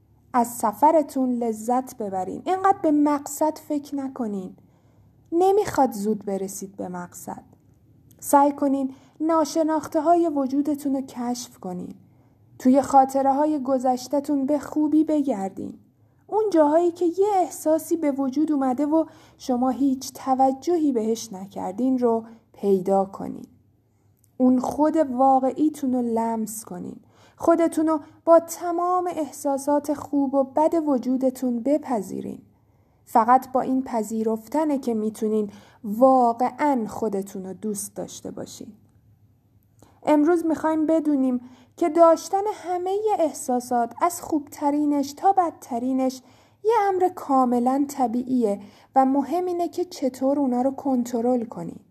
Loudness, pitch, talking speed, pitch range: -23 LUFS, 270 Hz, 115 wpm, 235-310 Hz